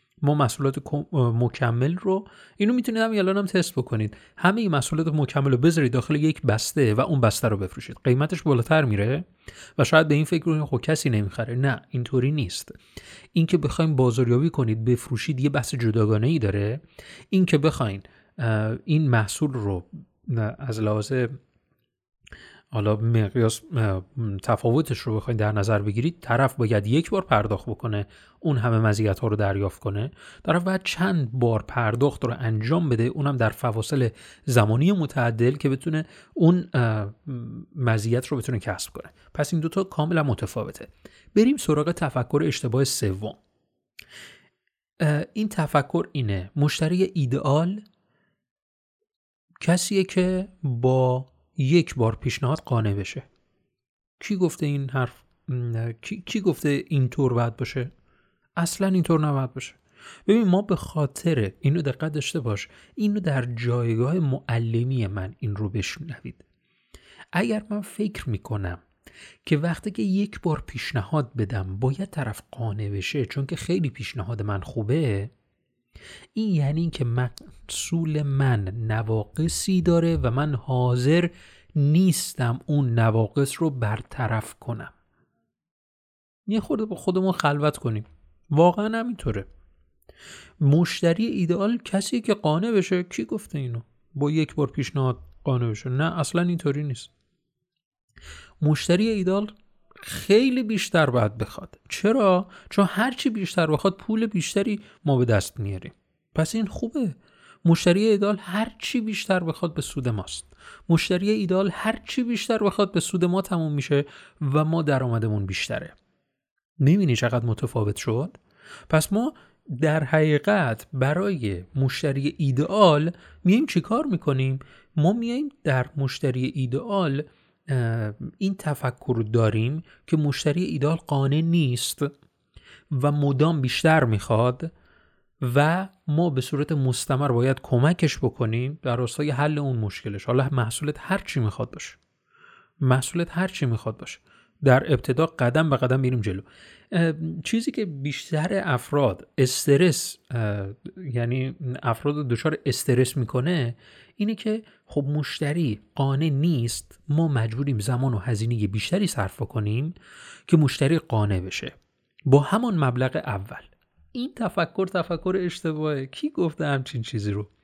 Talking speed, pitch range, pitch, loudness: 130 wpm, 120-170 Hz, 140 Hz, -24 LUFS